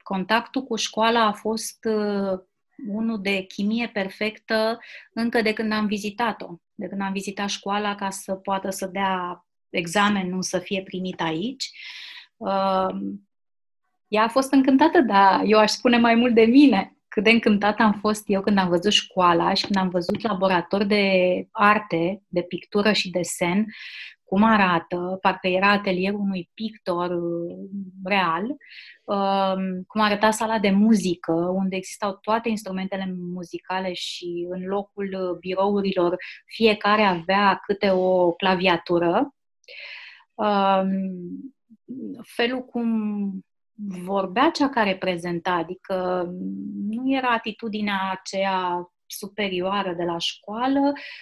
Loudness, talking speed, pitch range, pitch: -23 LUFS, 125 wpm, 185-220 Hz, 195 Hz